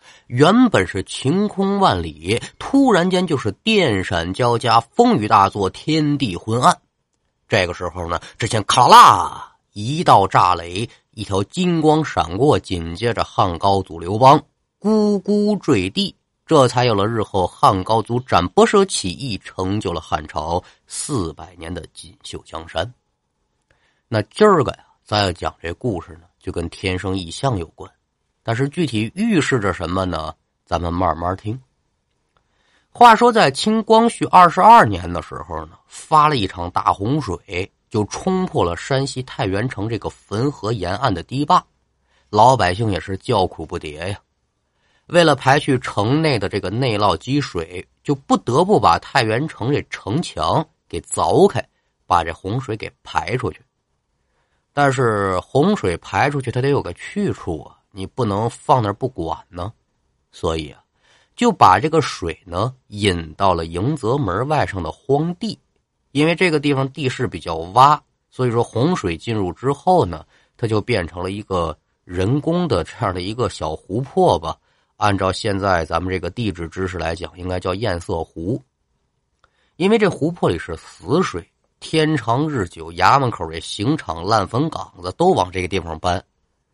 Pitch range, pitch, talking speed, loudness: 90-145 Hz, 110 Hz, 230 characters per minute, -18 LUFS